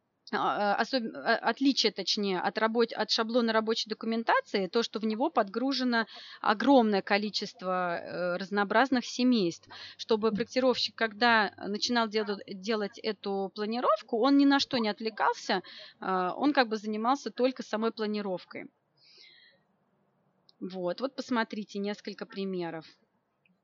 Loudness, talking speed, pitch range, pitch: -29 LUFS, 110 wpm, 200-235 Hz, 220 Hz